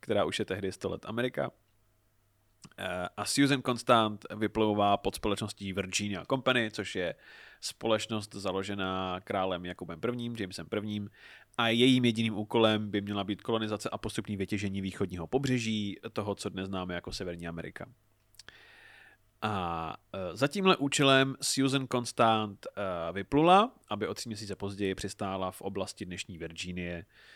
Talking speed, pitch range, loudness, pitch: 135 wpm, 95-115 Hz, -31 LUFS, 105 Hz